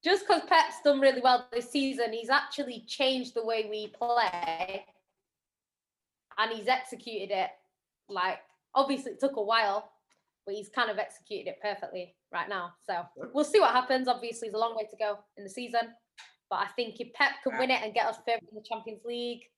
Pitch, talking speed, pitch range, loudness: 235 Hz, 200 wpm, 210-260 Hz, -30 LUFS